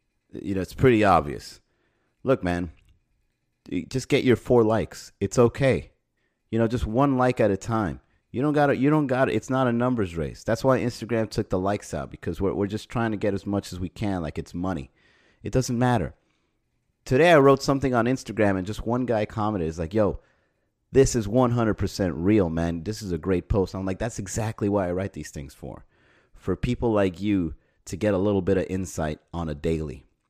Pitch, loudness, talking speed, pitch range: 105 Hz, -24 LUFS, 210 wpm, 90-120 Hz